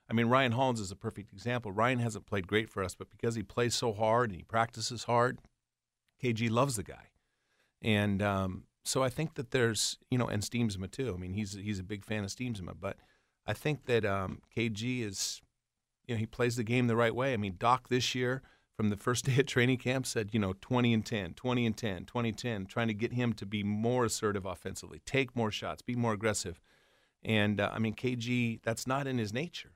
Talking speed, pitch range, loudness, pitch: 230 wpm, 105-125 Hz, -33 LUFS, 115 Hz